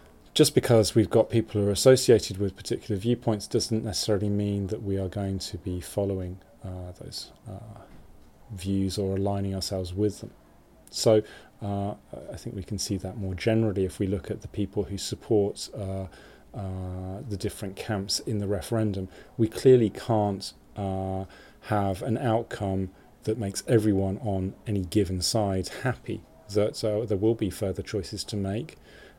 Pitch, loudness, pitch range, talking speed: 100 Hz, -27 LUFS, 95-110 Hz, 160 wpm